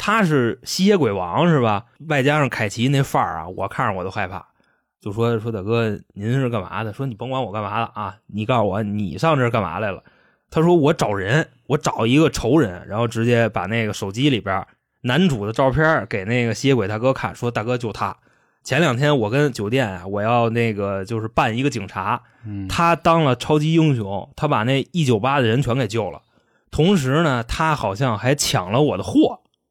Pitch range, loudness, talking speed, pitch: 110-145 Hz, -20 LUFS, 290 characters per minute, 120 Hz